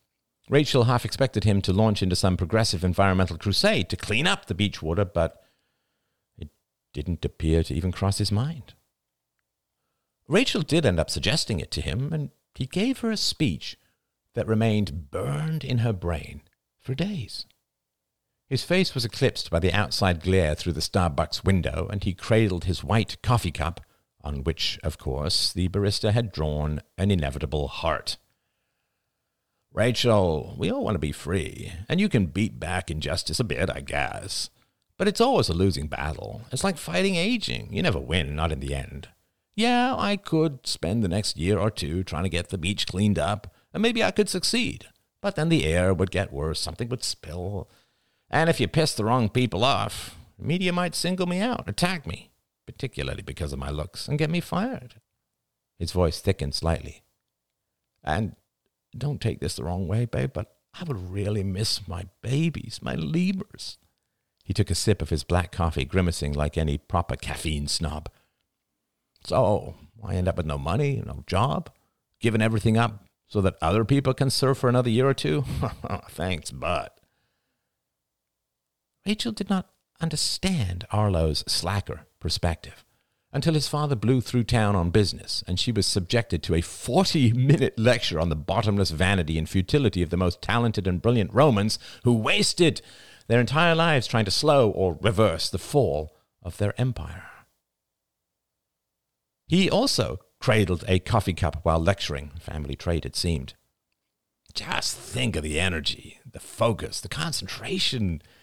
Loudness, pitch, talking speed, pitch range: -25 LUFS, 100 Hz, 165 wpm, 85-125 Hz